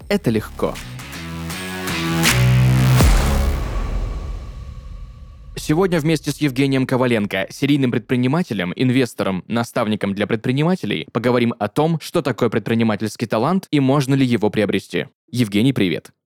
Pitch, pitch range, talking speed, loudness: 115 Hz, 95-135 Hz, 100 wpm, -19 LUFS